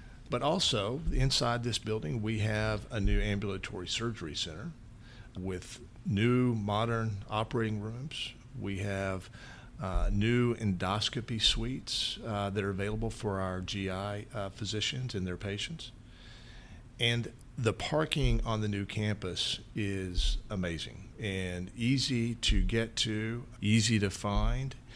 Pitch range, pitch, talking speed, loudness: 100-120 Hz, 110 Hz, 125 wpm, -33 LUFS